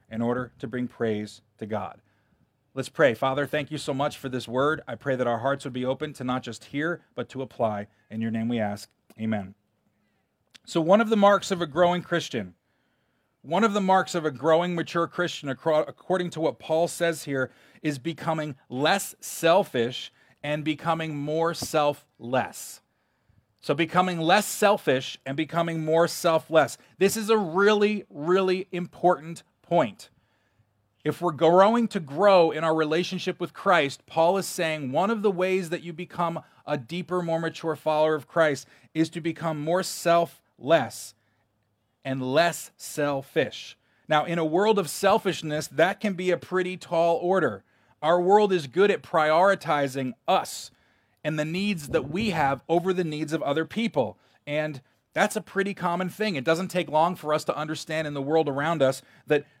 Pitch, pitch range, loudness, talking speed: 160 Hz, 135-175 Hz, -25 LUFS, 175 wpm